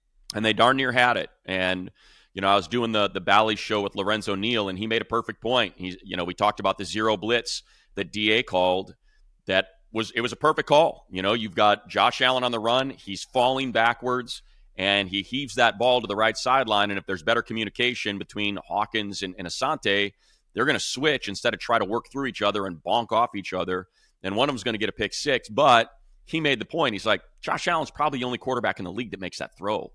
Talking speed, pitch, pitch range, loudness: 245 wpm, 110 Hz, 100-120 Hz, -24 LUFS